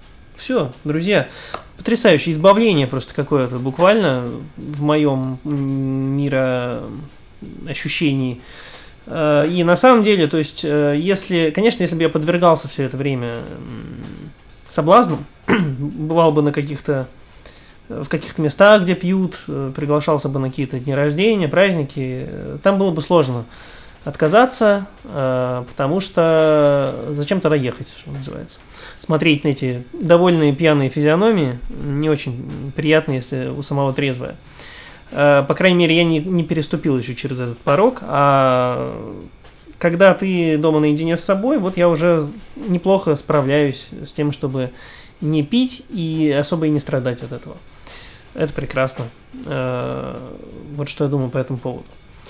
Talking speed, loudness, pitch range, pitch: 125 wpm, -17 LUFS, 135-170 Hz, 150 Hz